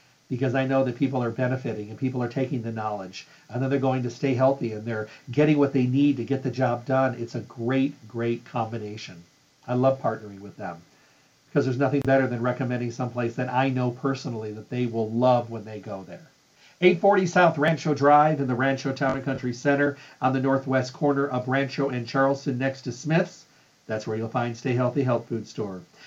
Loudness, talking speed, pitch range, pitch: -25 LUFS, 210 wpm, 120-135 Hz, 130 Hz